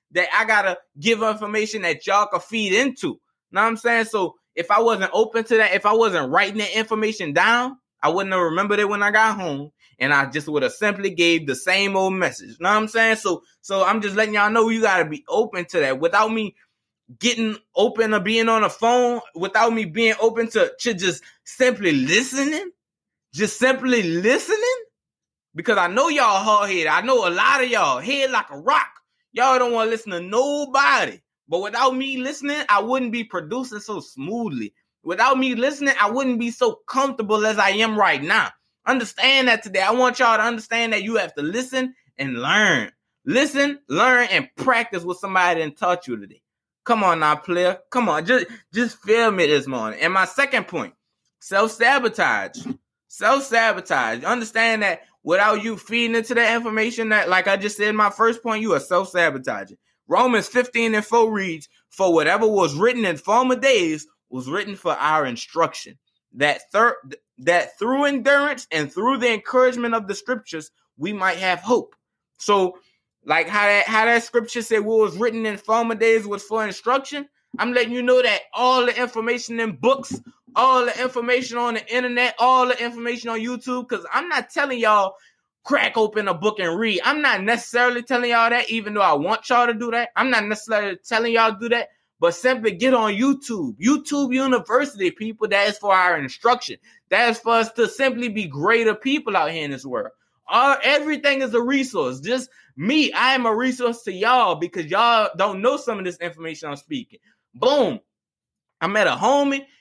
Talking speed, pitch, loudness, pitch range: 190 wpm, 225 Hz, -20 LUFS, 200-250 Hz